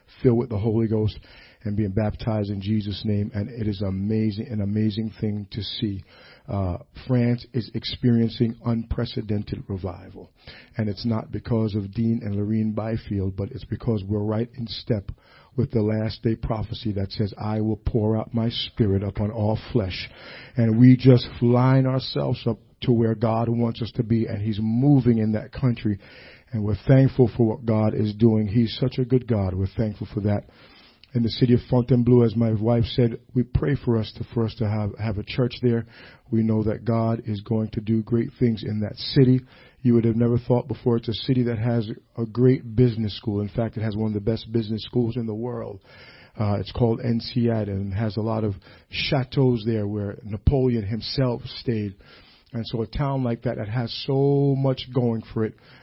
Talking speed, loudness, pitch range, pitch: 200 wpm, -24 LUFS, 105-120 Hz, 115 Hz